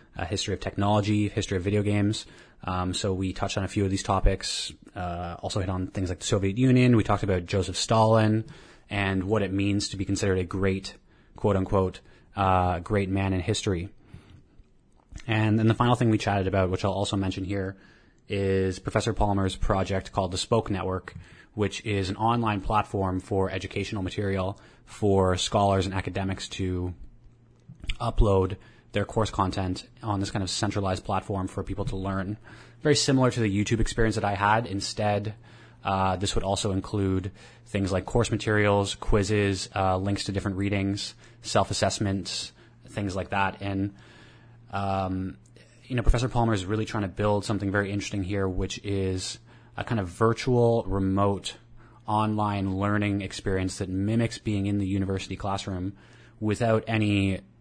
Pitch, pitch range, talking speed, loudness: 100 Hz, 95-110 Hz, 165 wpm, -27 LUFS